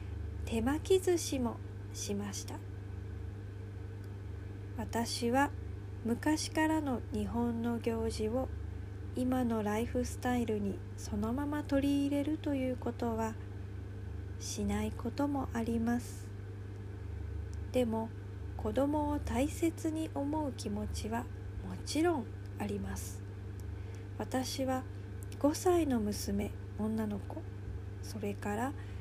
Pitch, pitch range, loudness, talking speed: 100 Hz, 100-115 Hz, -36 LUFS, 190 characters per minute